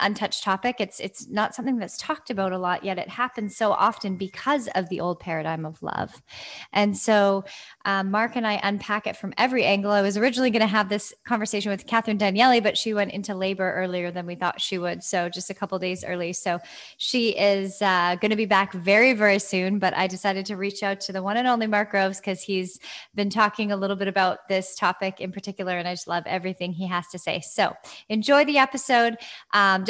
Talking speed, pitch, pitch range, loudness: 225 wpm, 200 Hz, 185-215 Hz, -24 LUFS